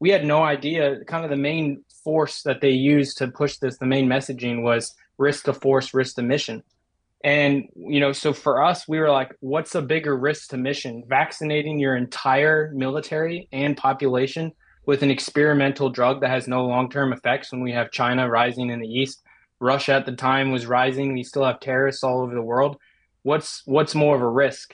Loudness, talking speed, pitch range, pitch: -22 LUFS, 200 wpm, 130-145 Hz, 135 Hz